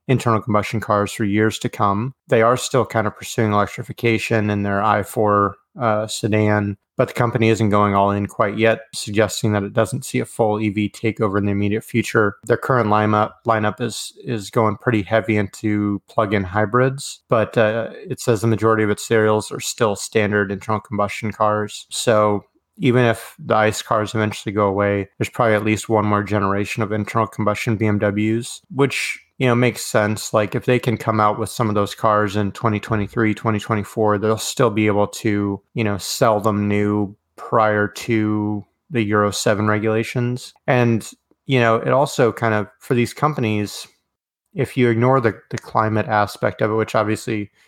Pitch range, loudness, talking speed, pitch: 105-115 Hz, -19 LUFS, 180 wpm, 110 Hz